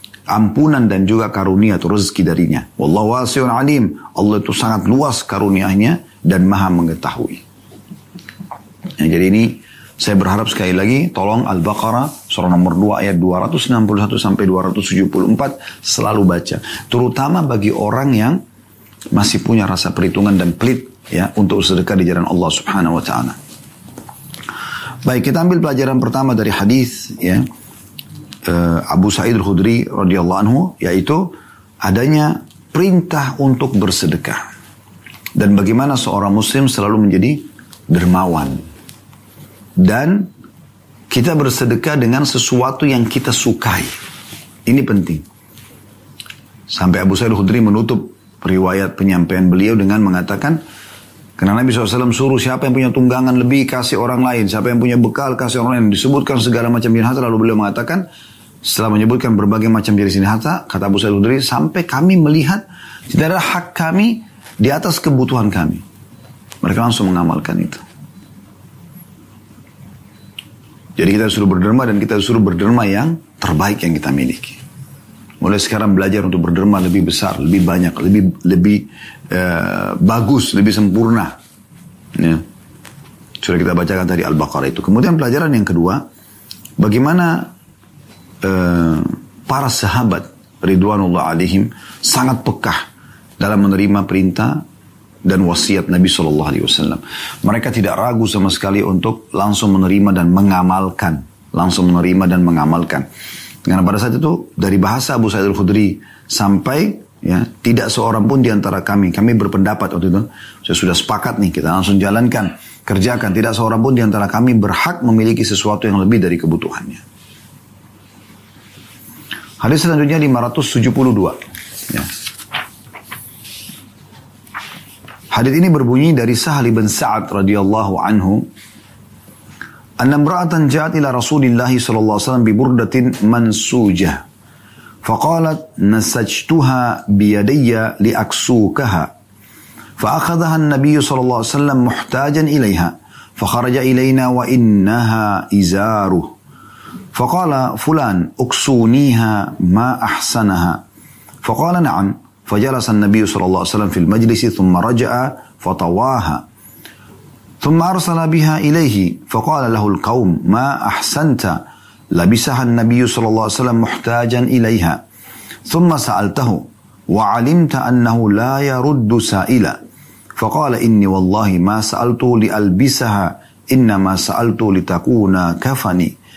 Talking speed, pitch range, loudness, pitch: 120 wpm, 95-125 Hz, -14 LUFS, 110 Hz